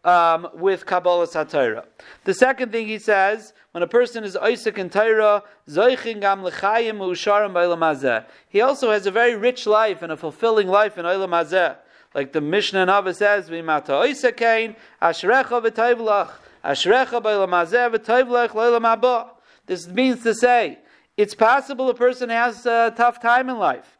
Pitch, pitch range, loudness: 215 Hz, 185-240 Hz, -19 LUFS